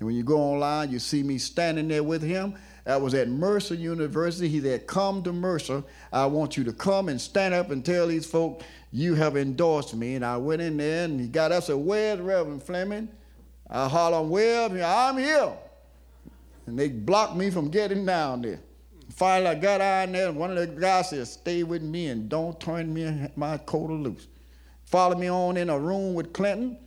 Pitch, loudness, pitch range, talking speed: 165 Hz, -26 LUFS, 140-185 Hz, 210 wpm